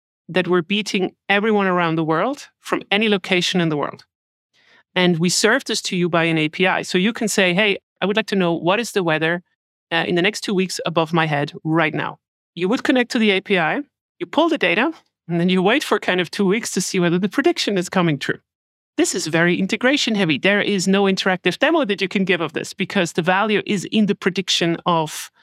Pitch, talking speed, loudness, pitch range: 190 Hz, 230 wpm, -19 LUFS, 175-210 Hz